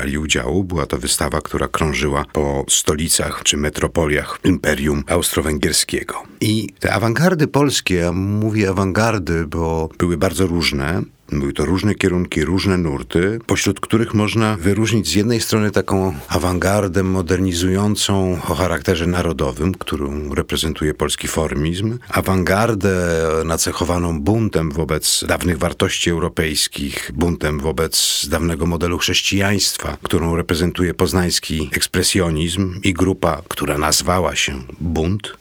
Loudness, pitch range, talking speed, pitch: -18 LUFS, 80-95 Hz, 115 wpm, 90 Hz